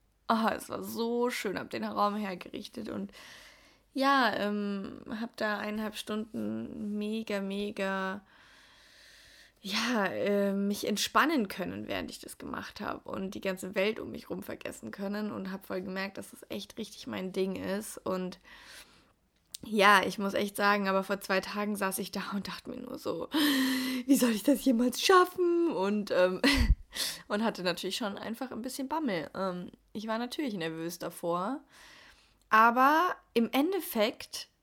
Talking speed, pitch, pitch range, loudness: 160 wpm, 210 Hz, 195-245 Hz, -31 LUFS